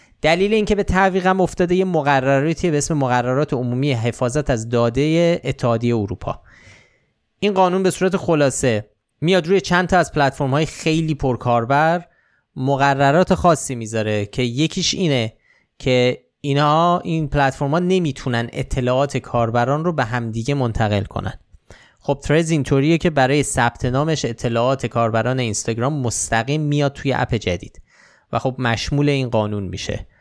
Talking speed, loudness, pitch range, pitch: 135 wpm, -19 LUFS, 120-160 Hz, 140 Hz